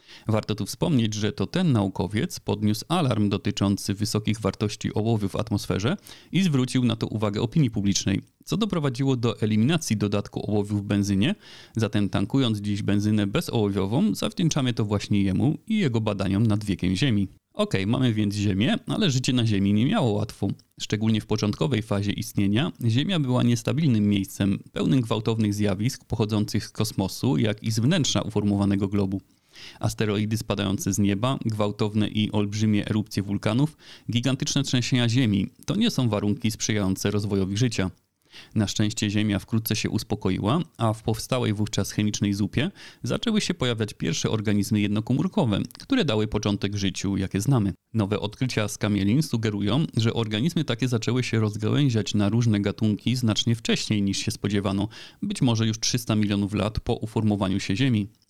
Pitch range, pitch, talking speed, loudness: 100-125 Hz, 110 Hz, 155 wpm, -25 LUFS